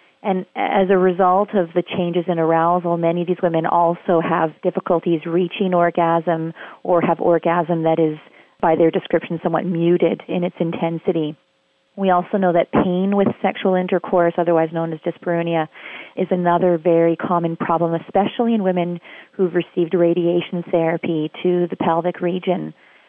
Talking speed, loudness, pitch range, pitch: 155 wpm, -19 LUFS, 165-180 Hz, 175 Hz